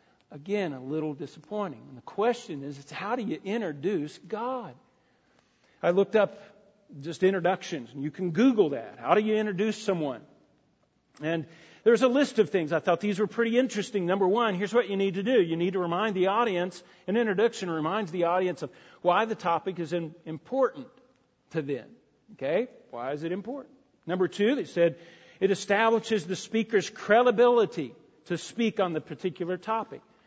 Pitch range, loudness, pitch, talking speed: 170-220 Hz, -28 LUFS, 195 Hz, 175 wpm